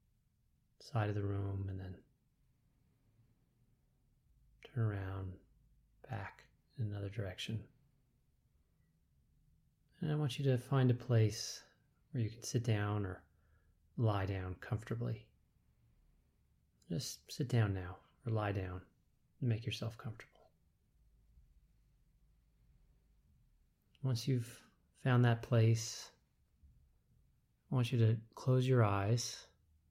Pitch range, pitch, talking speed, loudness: 90-125 Hz, 110 Hz, 105 wpm, -38 LUFS